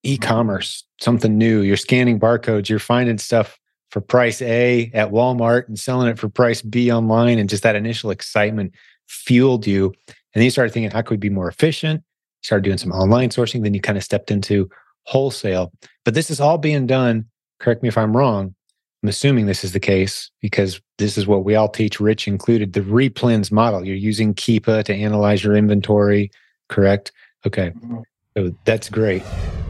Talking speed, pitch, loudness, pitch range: 185 wpm, 110 Hz, -18 LUFS, 100-120 Hz